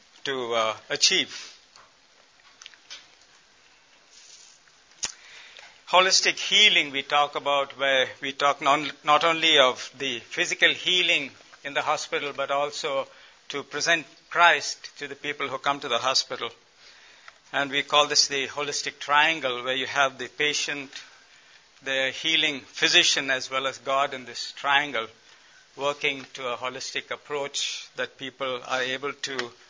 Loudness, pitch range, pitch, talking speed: -24 LUFS, 135-150 Hz, 140 Hz, 135 wpm